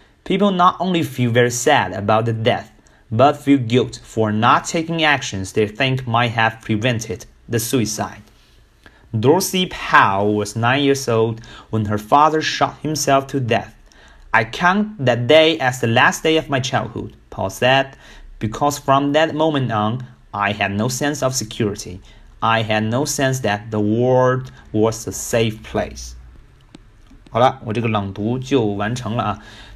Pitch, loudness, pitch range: 120 Hz, -18 LUFS, 110-135 Hz